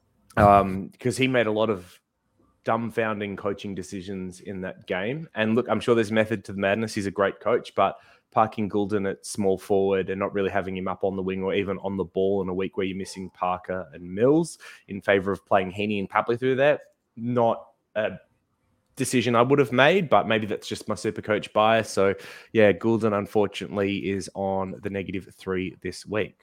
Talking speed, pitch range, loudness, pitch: 205 wpm, 95-110 Hz, -25 LUFS, 100 Hz